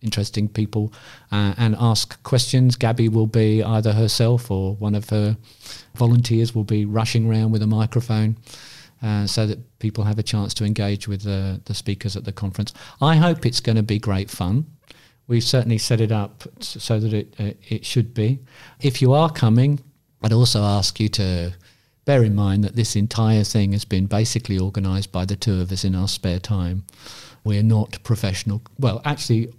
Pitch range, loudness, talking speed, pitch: 105-120 Hz, -21 LUFS, 190 wpm, 110 Hz